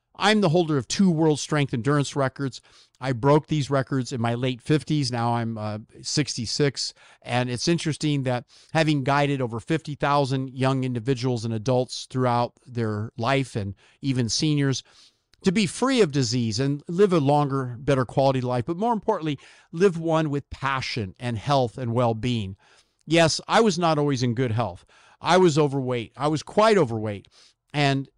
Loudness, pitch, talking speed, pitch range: -24 LUFS, 135 Hz, 170 wpm, 125-155 Hz